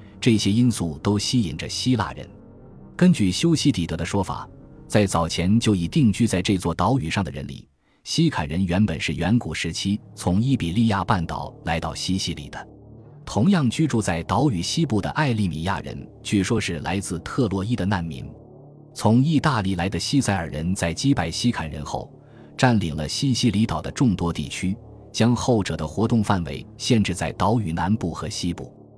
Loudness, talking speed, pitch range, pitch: -23 LUFS, 275 characters per minute, 85-120 Hz, 100 Hz